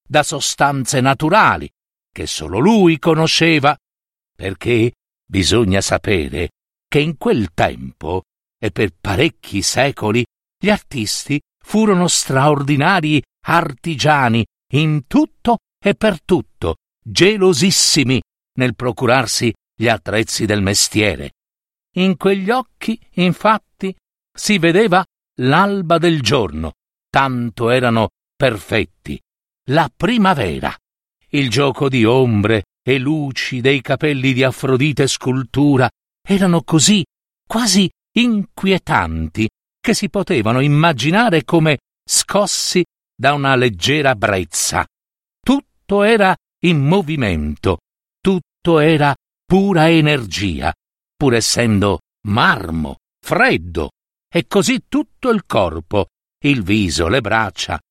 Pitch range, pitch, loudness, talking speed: 110-175 Hz, 140 Hz, -16 LUFS, 100 wpm